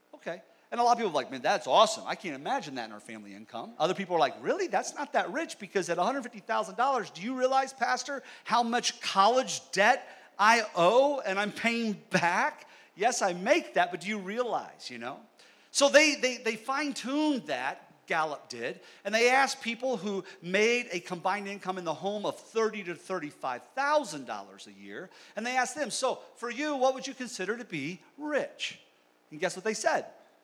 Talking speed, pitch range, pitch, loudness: 200 wpm, 185-265 Hz, 225 Hz, -29 LUFS